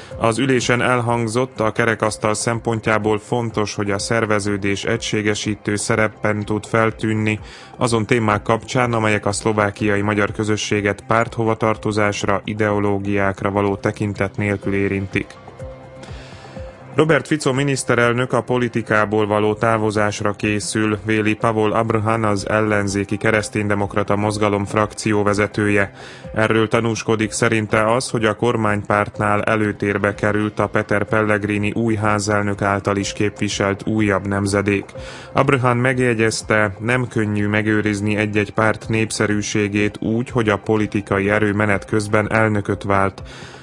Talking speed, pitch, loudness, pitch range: 110 wpm, 105 Hz, -19 LUFS, 105-110 Hz